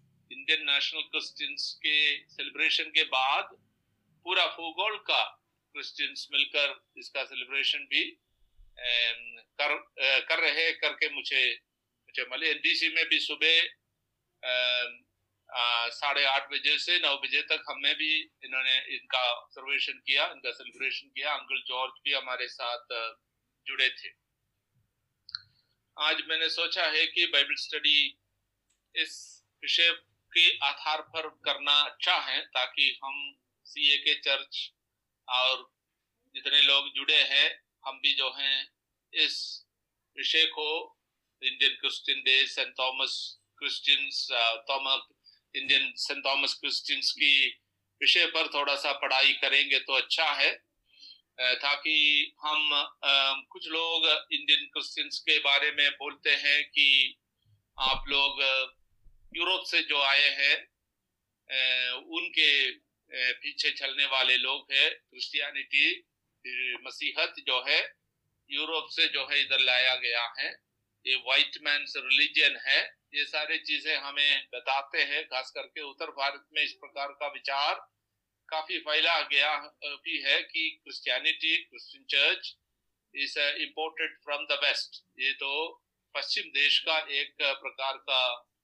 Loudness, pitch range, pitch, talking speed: -26 LUFS, 130-155 Hz, 140 Hz, 115 wpm